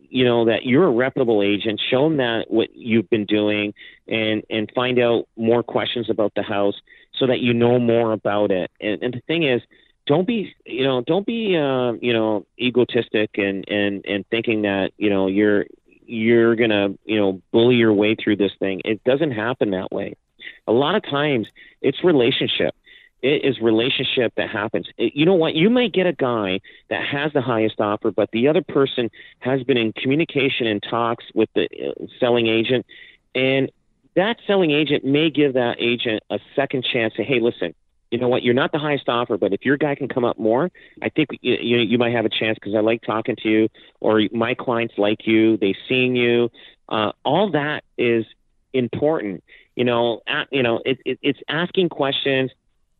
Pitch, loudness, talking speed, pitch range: 120 Hz, -20 LUFS, 200 wpm, 110-130 Hz